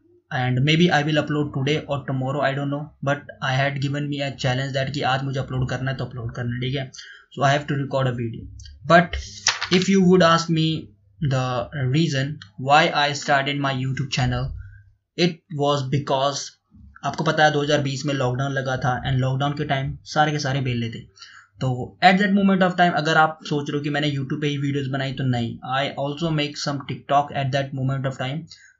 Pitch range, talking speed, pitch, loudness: 130-150 Hz, 215 wpm, 140 Hz, -22 LUFS